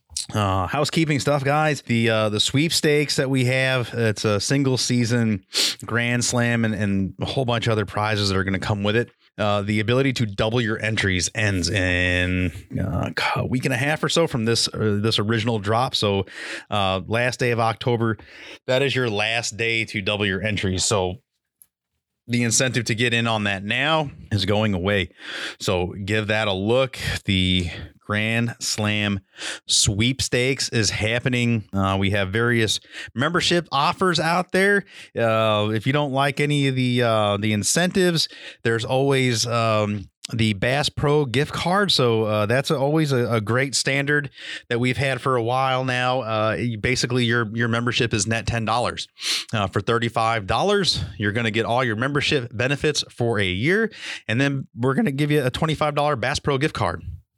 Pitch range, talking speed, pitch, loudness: 105-135 Hz, 180 wpm, 115 Hz, -21 LUFS